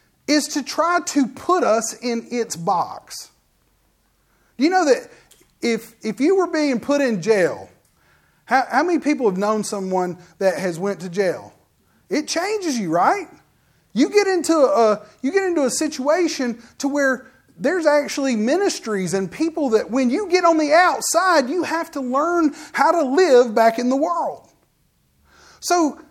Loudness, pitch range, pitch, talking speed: -19 LUFS, 225-330 Hz, 280 Hz, 165 wpm